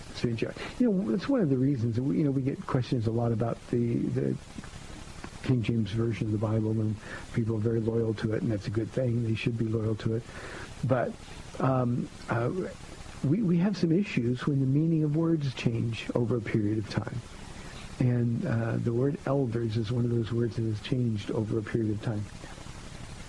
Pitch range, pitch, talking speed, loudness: 115-130 Hz, 120 Hz, 205 wpm, -29 LUFS